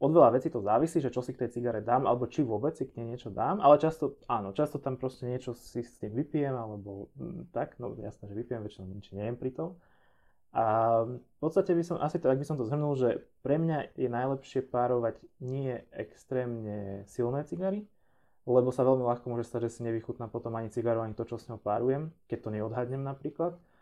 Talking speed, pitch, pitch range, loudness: 220 wpm, 125 Hz, 115-145 Hz, -31 LUFS